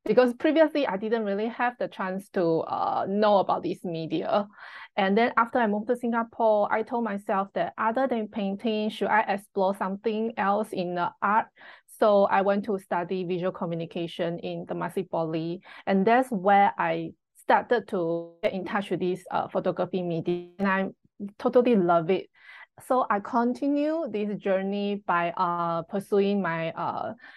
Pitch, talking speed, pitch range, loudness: 200 Hz, 165 wpm, 180-225 Hz, -26 LUFS